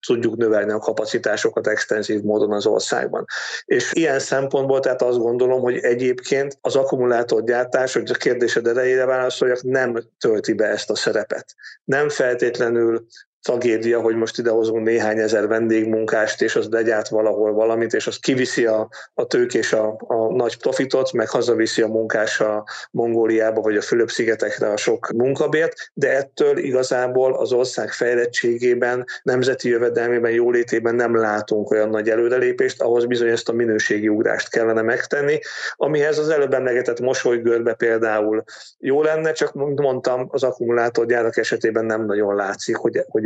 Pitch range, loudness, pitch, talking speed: 110-130 Hz, -20 LUFS, 120 Hz, 145 wpm